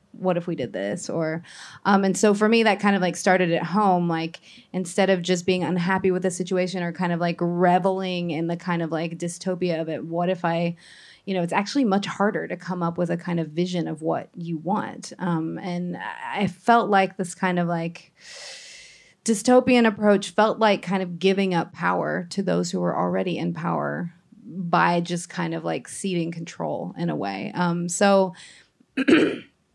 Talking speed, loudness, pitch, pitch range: 200 wpm, -23 LUFS, 180 Hz, 170-195 Hz